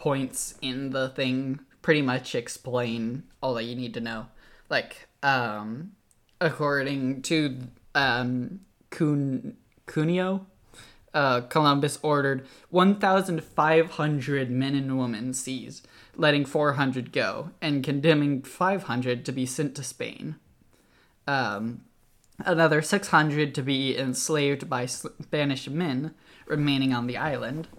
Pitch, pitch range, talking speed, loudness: 140 Hz, 125-155 Hz, 110 wpm, -26 LUFS